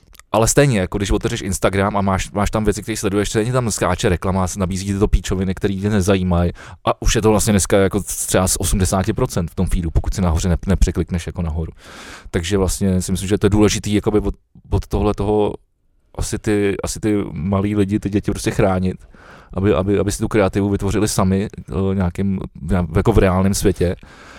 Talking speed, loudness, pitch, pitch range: 200 wpm, -18 LUFS, 100 Hz, 95-105 Hz